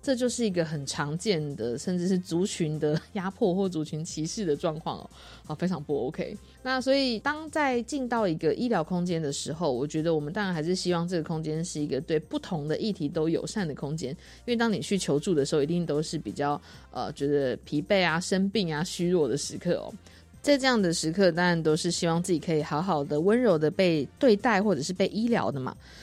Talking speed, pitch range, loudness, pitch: 325 characters per minute, 155-205 Hz, -28 LUFS, 175 Hz